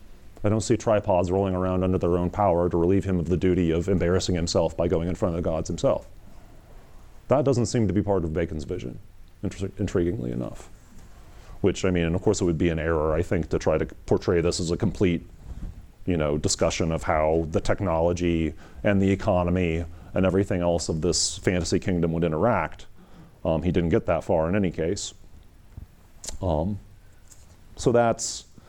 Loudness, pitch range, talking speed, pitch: -25 LUFS, 85-100 Hz, 190 wpm, 90 Hz